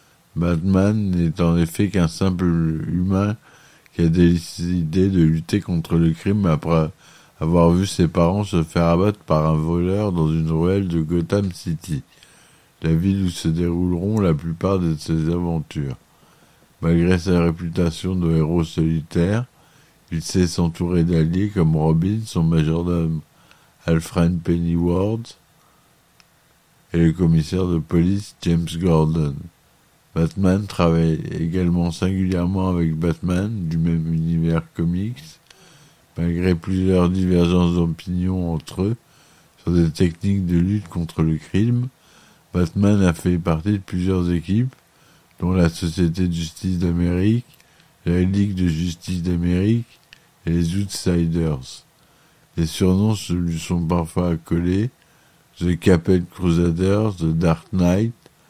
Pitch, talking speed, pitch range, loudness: 85 Hz, 125 wpm, 85-95 Hz, -20 LUFS